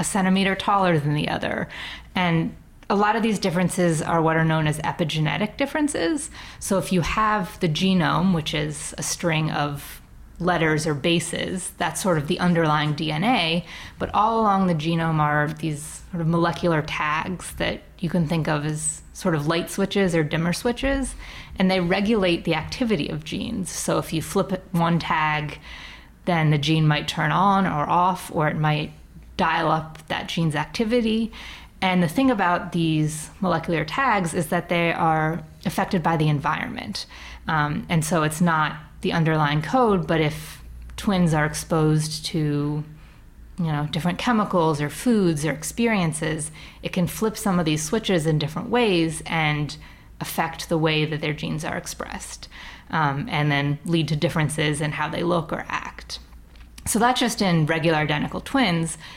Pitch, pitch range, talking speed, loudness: 165 Hz, 155-185 Hz, 170 wpm, -23 LUFS